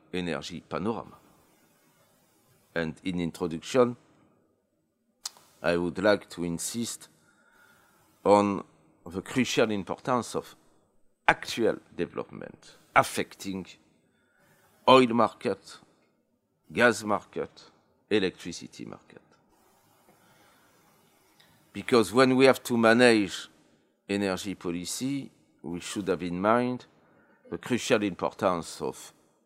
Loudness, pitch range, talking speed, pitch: -27 LUFS, 85-120 Hz, 85 wpm, 100 Hz